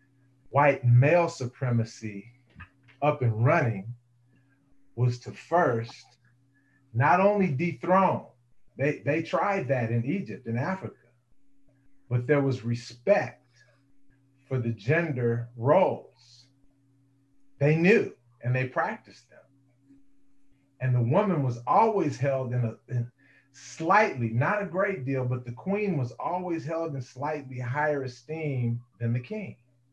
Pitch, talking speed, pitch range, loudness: 135 Hz, 120 wpm, 120-145 Hz, -27 LUFS